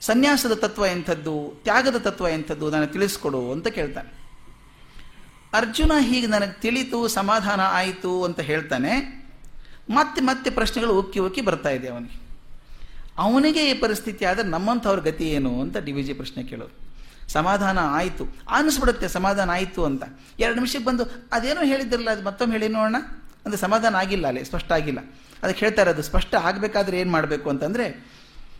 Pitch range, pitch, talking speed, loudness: 155-235 Hz, 195 Hz, 145 wpm, -23 LUFS